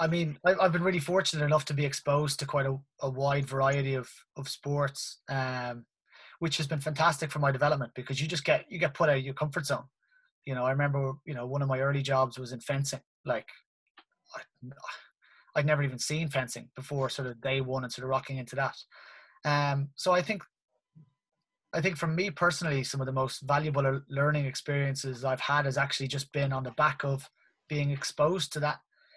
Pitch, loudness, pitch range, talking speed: 140 Hz, -30 LUFS, 135-150 Hz, 210 wpm